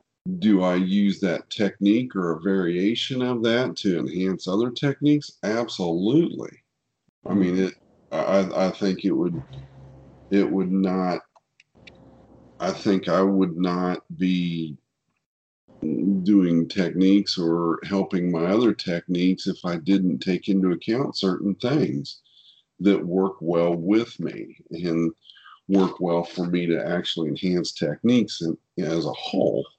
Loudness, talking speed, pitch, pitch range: -23 LUFS, 130 wpm, 95 Hz, 85-100 Hz